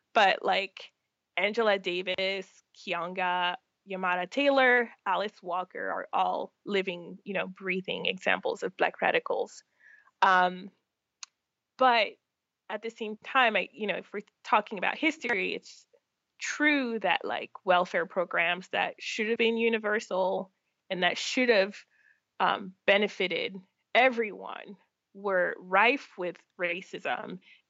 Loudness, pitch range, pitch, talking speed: -28 LUFS, 185-230 Hz, 200 Hz, 120 wpm